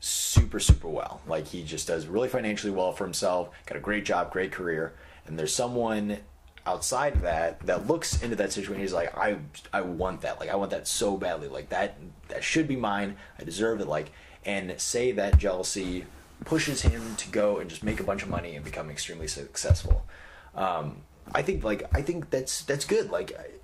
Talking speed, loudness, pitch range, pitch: 210 wpm, -29 LUFS, 80-115 Hz, 95 Hz